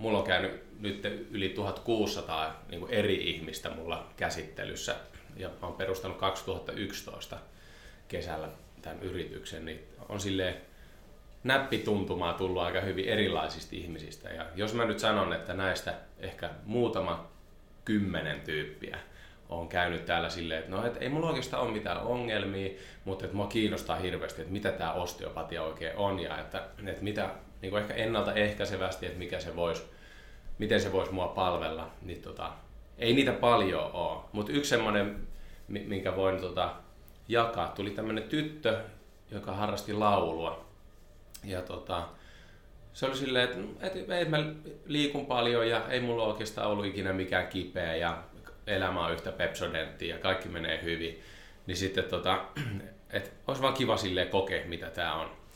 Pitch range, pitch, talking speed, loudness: 85-105 Hz, 95 Hz, 145 wpm, -33 LUFS